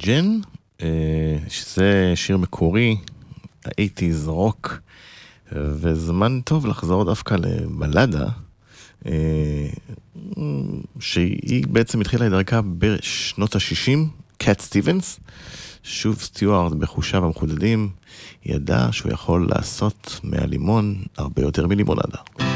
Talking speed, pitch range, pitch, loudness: 85 wpm, 85-110 Hz, 100 Hz, -21 LUFS